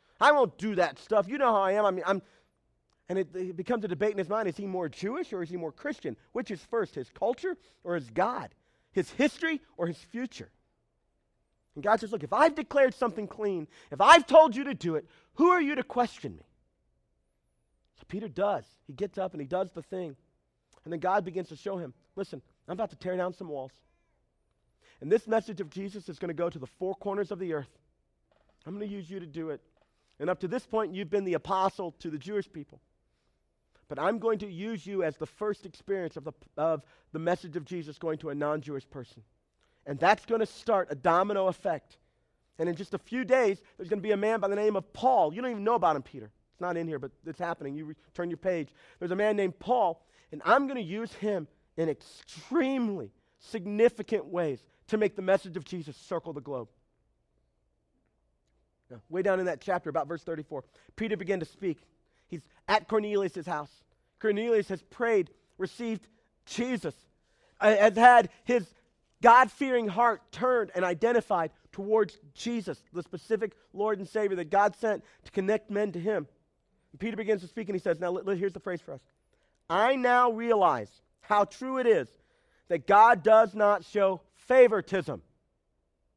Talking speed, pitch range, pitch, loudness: 205 wpm, 165-220 Hz, 195 Hz, -29 LUFS